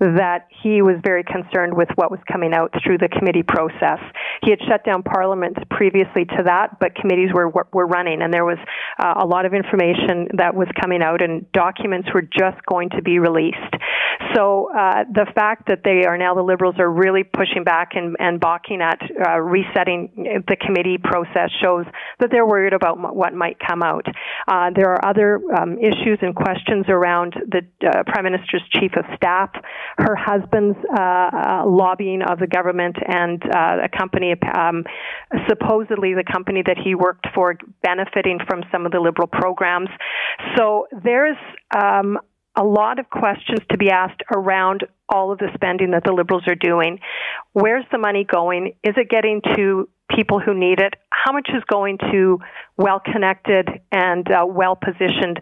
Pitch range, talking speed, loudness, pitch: 180-200 Hz, 180 wpm, -18 LUFS, 185 Hz